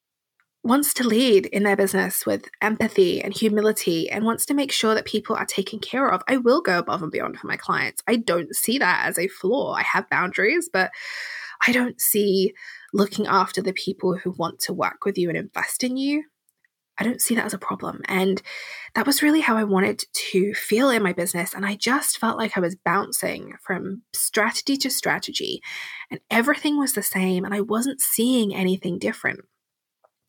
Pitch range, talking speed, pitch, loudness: 195-255 Hz, 200 wpm, 215 Hz, -22 LUFS